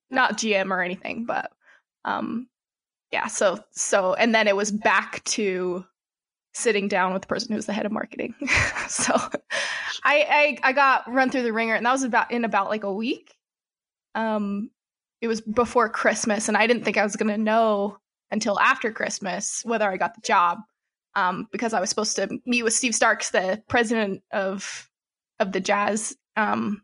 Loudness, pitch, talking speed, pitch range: -23 LUFS, 220 Hz, 185 wpm, 200-235 Hz